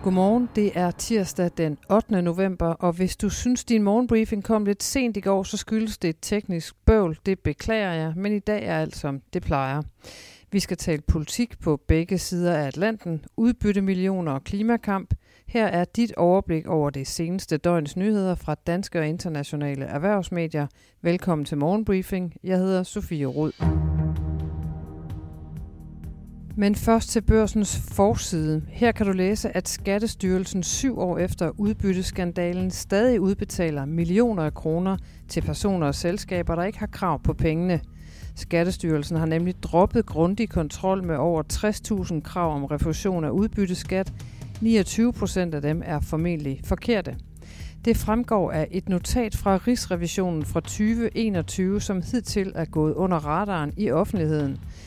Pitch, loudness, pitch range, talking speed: 180 Hz, -25 LUFS, 155-205 Hz, 150 wpm